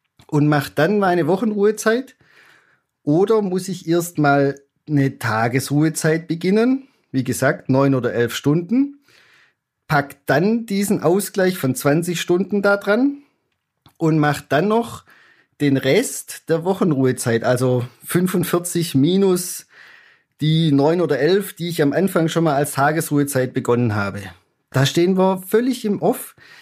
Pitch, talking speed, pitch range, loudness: 160 Hz, 135 wpm, 140-190 Hz, -19 LUFS